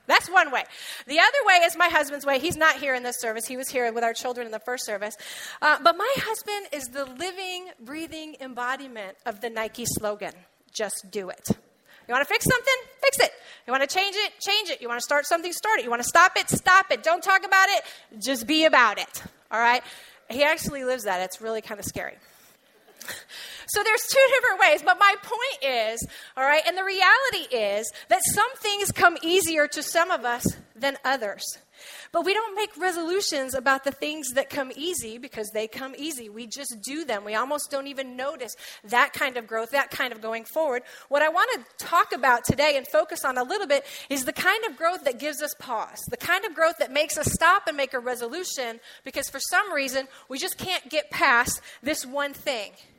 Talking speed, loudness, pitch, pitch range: 220 wpm, -24 LUFS, 285 Hz, 250-350 Hz